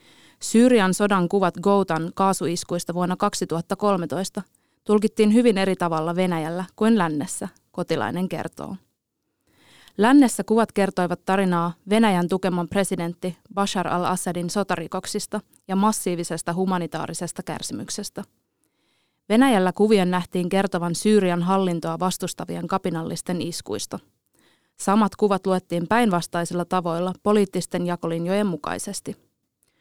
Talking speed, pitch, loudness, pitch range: 95 wpm, 185 Hz, -23 LUFS, 175-200 Hz